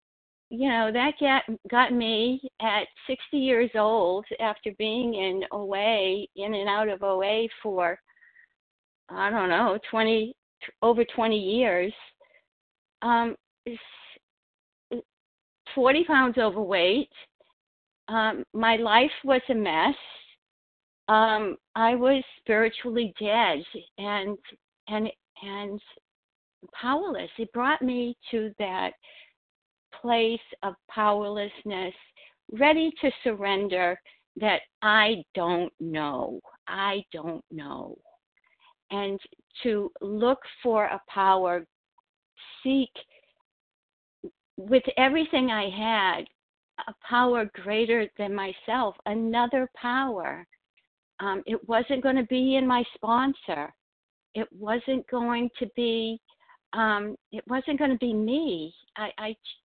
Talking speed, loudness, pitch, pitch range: 105 wpm, -26 LUFS, 225 Hz, 205-255 Hz